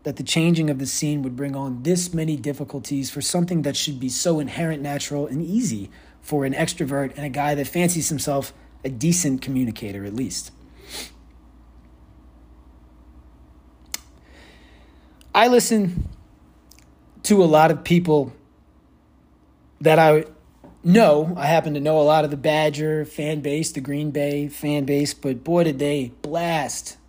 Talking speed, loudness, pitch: 150 wpm, -21 LUFS, 145 Hz